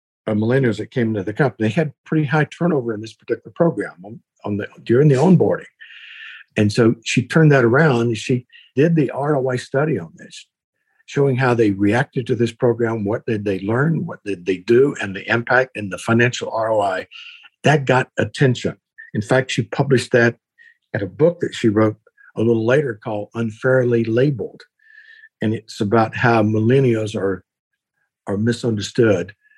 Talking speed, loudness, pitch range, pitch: 170 wpm, -19 LUFS, 110-140 Hz, 120 Hz